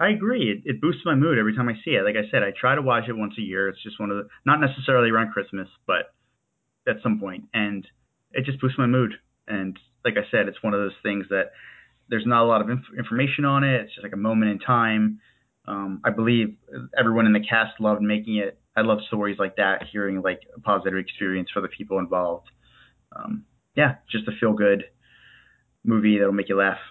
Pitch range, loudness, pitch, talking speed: 100-125 Hz, -23 LUFS, 110 Hz, 230 wpm